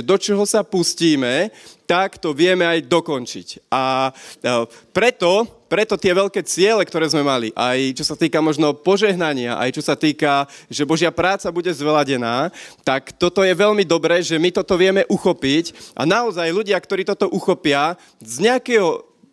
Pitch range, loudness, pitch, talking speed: 145-195 Hz, -18 LUFS, 170 Hz, 165 wpm